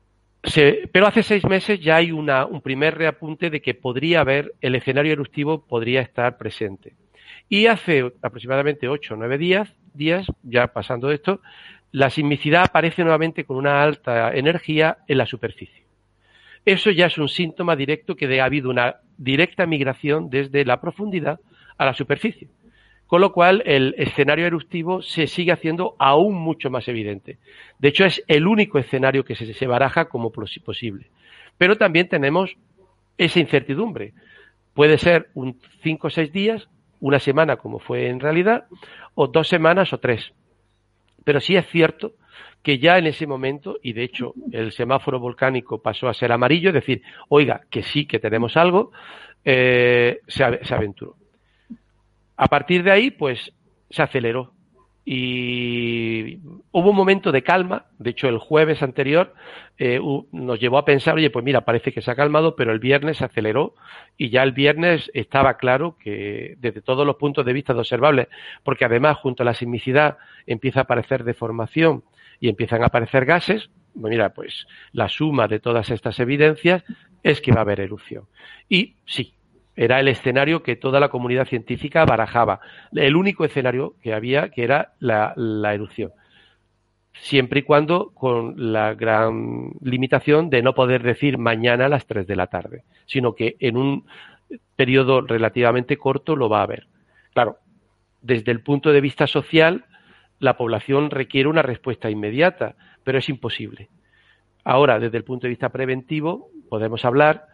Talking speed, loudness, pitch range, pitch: 165 wpm, -19 LUFS, 120-160 Hz, 135 Hz